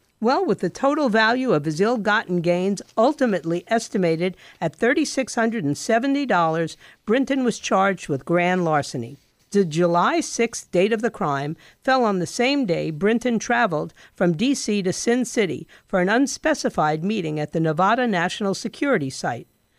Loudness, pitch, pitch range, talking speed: -22 LUFS, 205 Hz, 175-240 Hz, 165 wpm